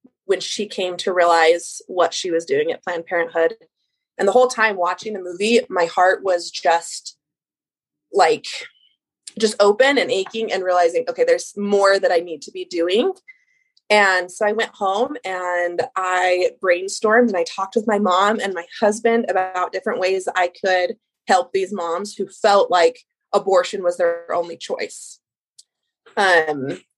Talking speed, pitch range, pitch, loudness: 160 wpm, 180-245 Hz, 200 Hz, -19 LUFS